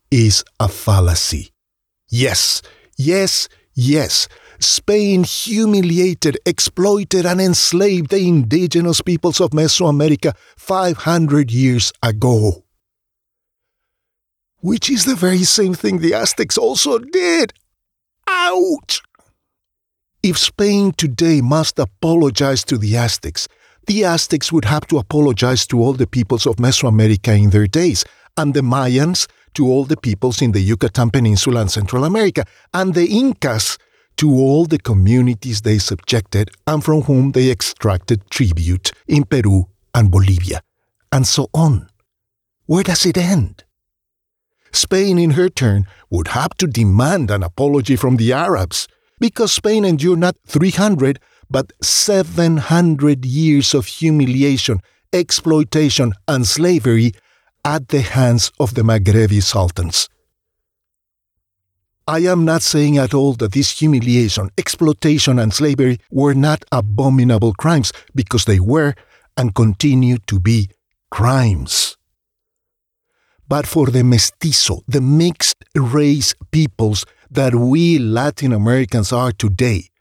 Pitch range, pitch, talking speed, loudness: 110-165 Hz, 135 Hz, 125 wpm, -15 LUFS